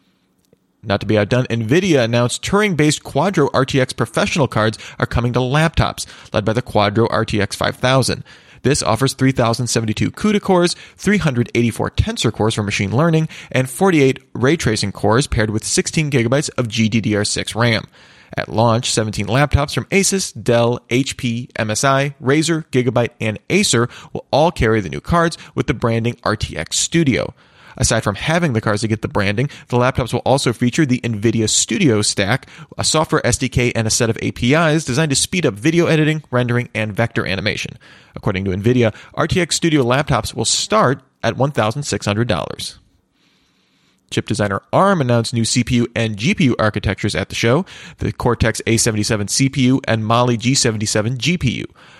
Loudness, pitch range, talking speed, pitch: -17 LUFS, 110-145 Hz, 155 wpm, 120 Hz